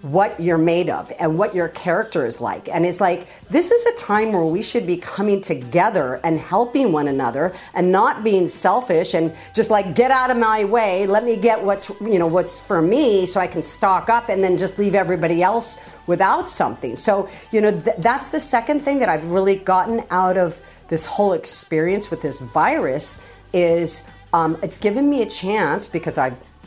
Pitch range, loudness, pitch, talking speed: 170-220 Hz, -19 LUFS, 190 Hz, 200 wpm